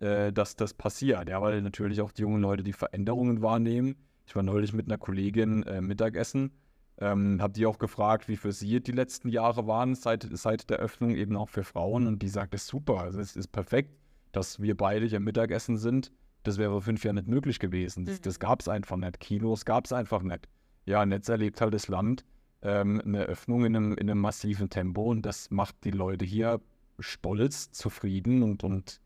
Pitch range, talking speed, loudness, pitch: 100-115 Hz, 205 wpm, -30 LUFS, 105 Hz